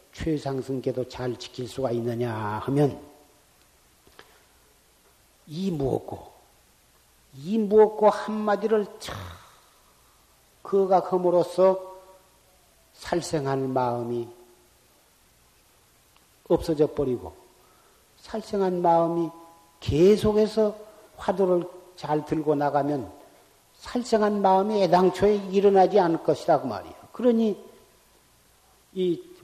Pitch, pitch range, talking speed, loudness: 170 Hz, 135-200 Hz, 200 characters per minute, -24 LUFS